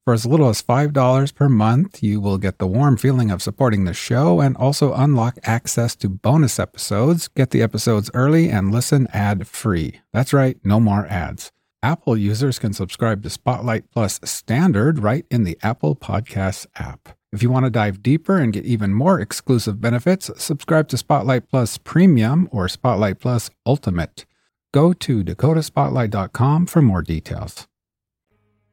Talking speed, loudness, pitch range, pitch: 165 wpm, -18 LUFS, 105-140 Hz, 120 Hz